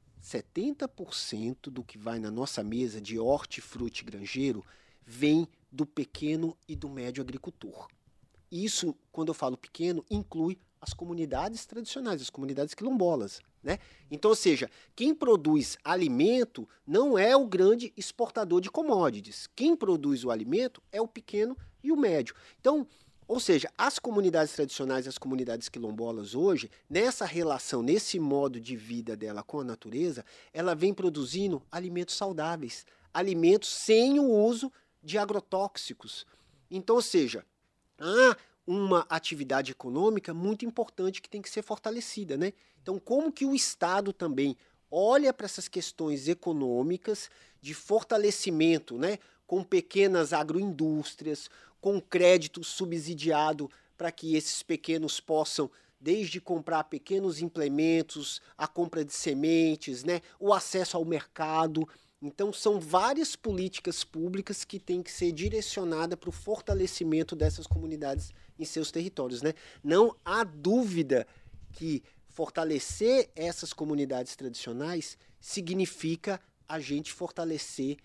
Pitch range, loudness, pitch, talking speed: 145-205 Hz, -30 LUFS, 170 Hz, 130 wpm